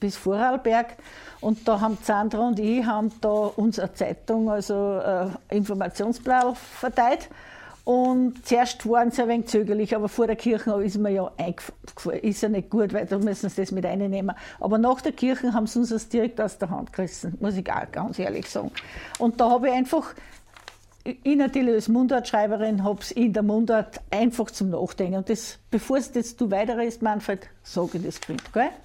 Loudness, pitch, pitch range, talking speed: -25 LUFS, 220 Hz, 205-240 Hz, 195 wpm